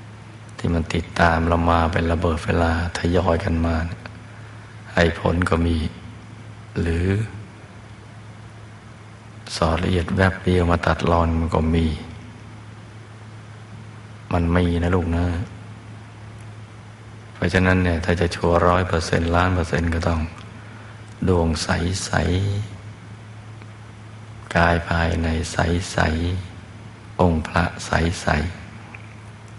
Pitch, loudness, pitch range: 95 Hz, -21 LUFS, 85-110 Hz